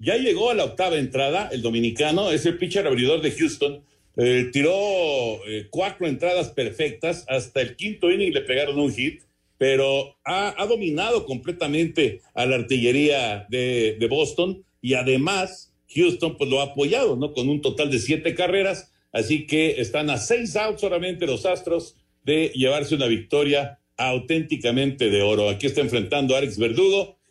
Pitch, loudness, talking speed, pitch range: 145 Hz, -22 LUFS, 165 wpm, 130-180 Hz